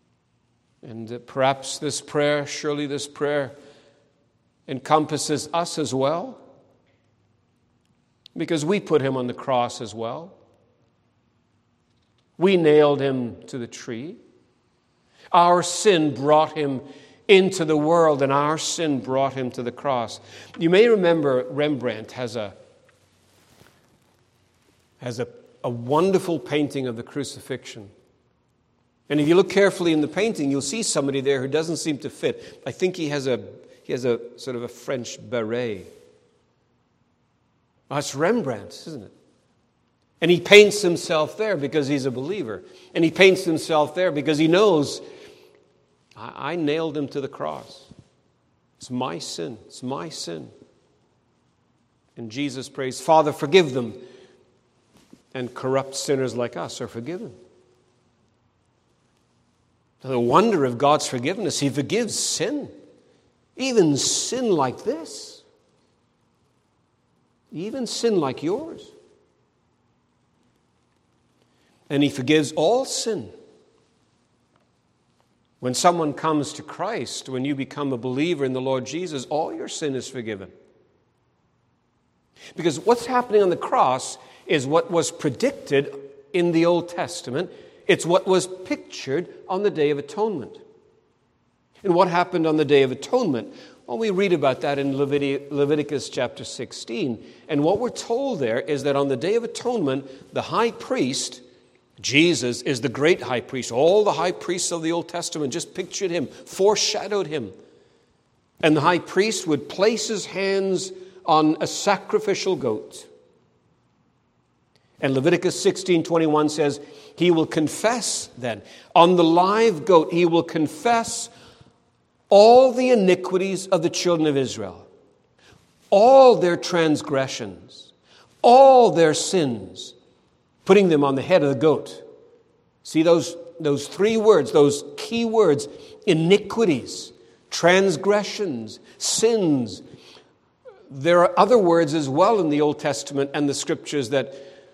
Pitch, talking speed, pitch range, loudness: 155 Hz, 135 wpm, 135-185 Hz, -21 LUFS